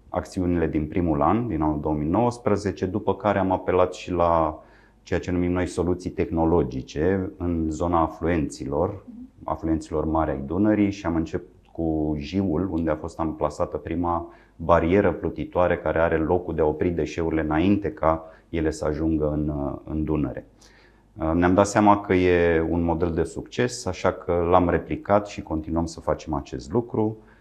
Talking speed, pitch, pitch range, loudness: 160 wpm, 85 Hz, 80-95 Hz, -24 LUFS